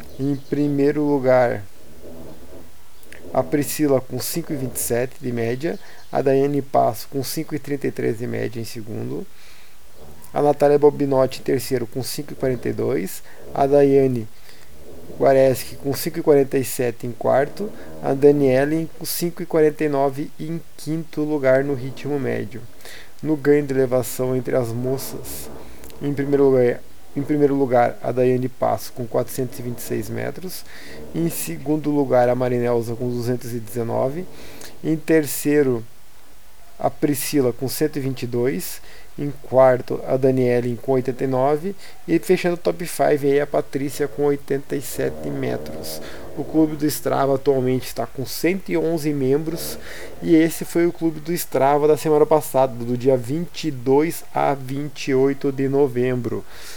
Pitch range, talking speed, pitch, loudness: 125-150 Hz, 125 wpm, 135 Hz, -21 LUFS